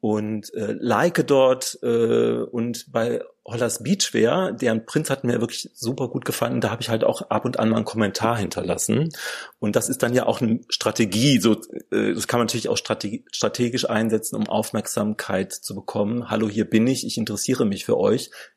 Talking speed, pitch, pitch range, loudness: 195 wpm, 115 Hz, 110-130 Hz, -23 LUFS